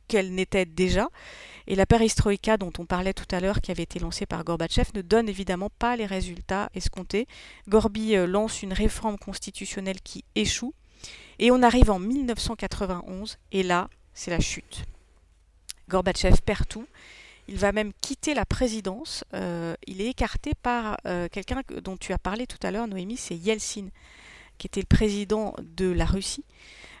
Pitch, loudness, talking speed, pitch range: 195 Hz, -27 LUFS, 165 wpm, 185-220 Hz